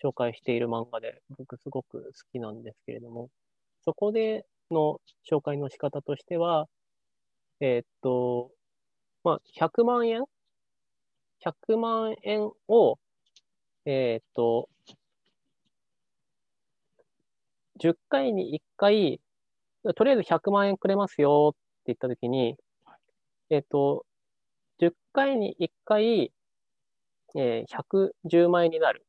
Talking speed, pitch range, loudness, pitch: 170 characters per minute, 130-200 Hz, -27 LUFS, 155 Hz